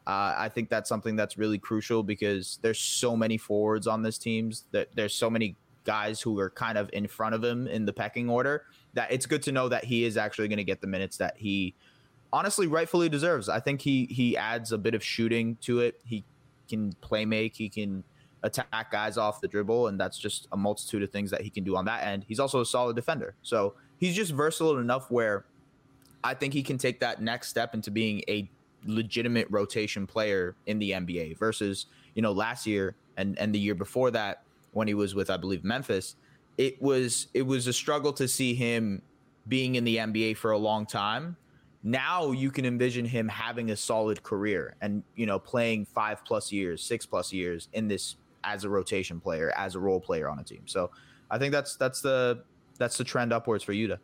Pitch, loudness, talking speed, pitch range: 110 Hz, -30 LUFS, 220 wpm, 105-125 Hz